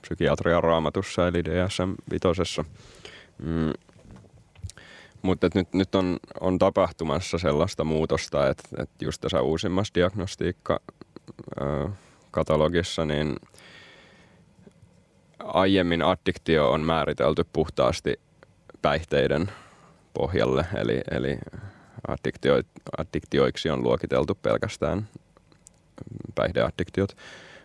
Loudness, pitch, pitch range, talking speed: -26 LUFS, 85 Hz, 80-95 Hz, 75 wpm